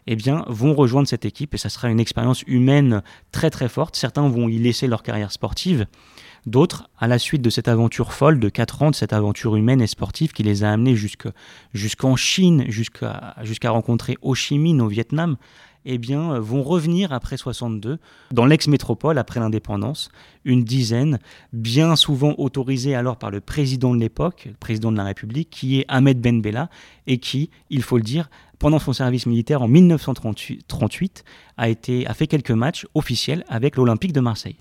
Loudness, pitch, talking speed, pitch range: -20 LUFS, 125 Hz, 185 wpm, 115-145 Hz